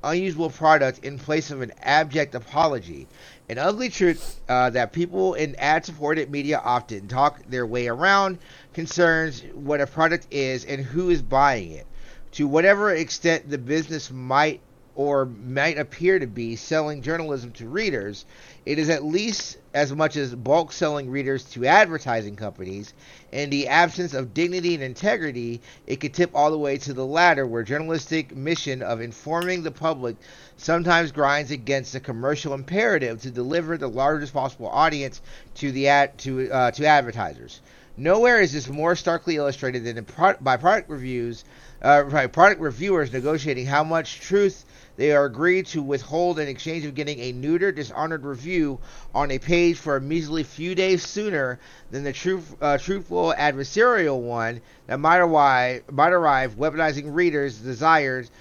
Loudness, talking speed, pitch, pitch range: -22 LUFS, 160 wpm, 145 Hz, 130-165 Hz